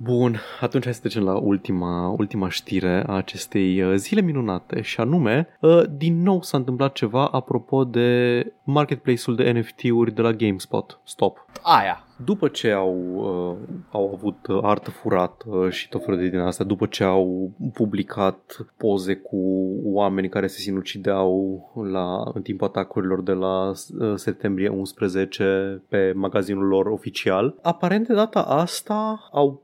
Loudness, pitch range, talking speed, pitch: -22 LUFS, 95-125 Hz, 150 wpm, 100 Hz